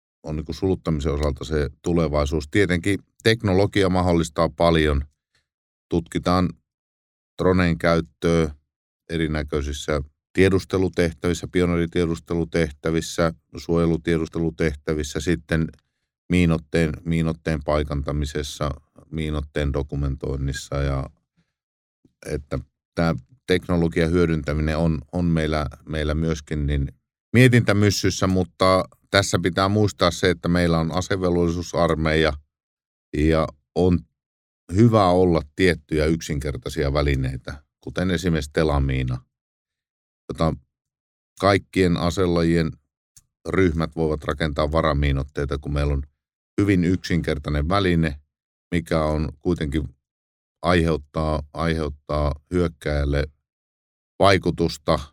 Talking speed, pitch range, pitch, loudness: 80 wpm, 75-85 Hz, 80 Hz, -22 LUFS